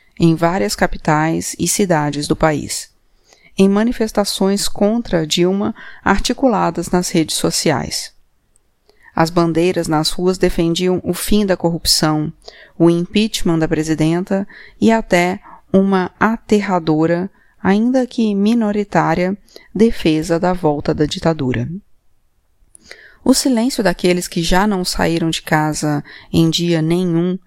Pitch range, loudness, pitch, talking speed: 165-200 Hz, -16 LUFS, 180 Hz, 115 wpm